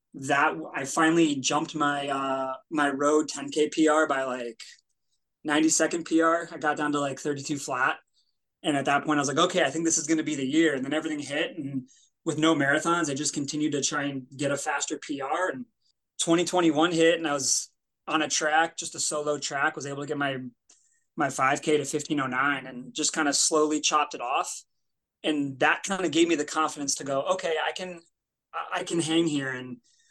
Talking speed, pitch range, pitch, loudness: 210 wpm, 140-165 Hz, 150 Hz, -26 LUFS